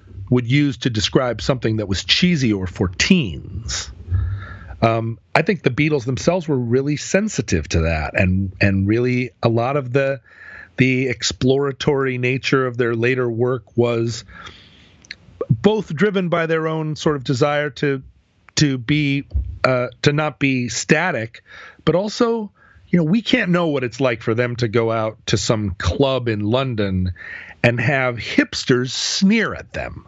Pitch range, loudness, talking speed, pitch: 110-150 Hz, -19 LUFS, 160 wpm, 125 Hz